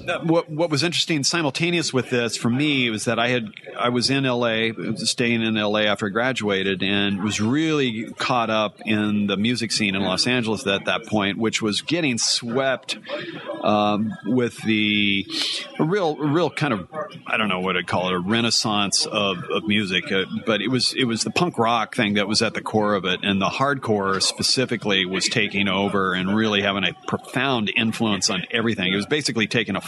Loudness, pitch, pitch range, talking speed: -21 LUFS, 110 Hz, 100-120 Hz, 200 wpm